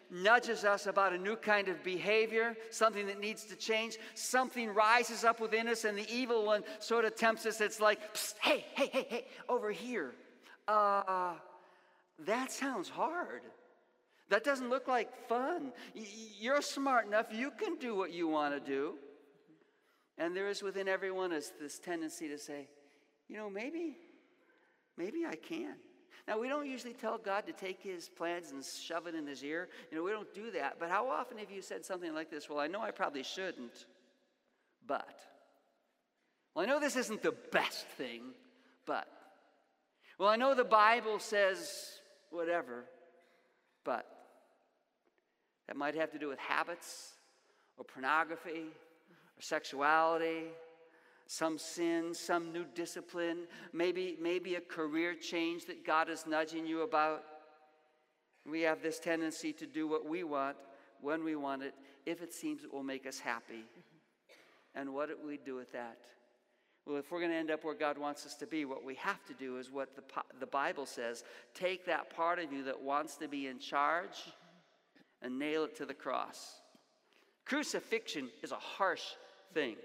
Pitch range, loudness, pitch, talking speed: 155-225 Hz, -37 LUFS, 175 Hz, 170 wpm